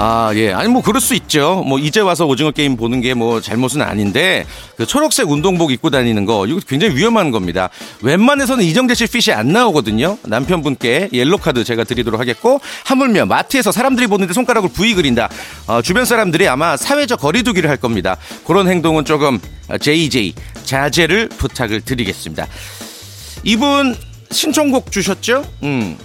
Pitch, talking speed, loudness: 150 Hz, 375 characters per minute, -14 LUFS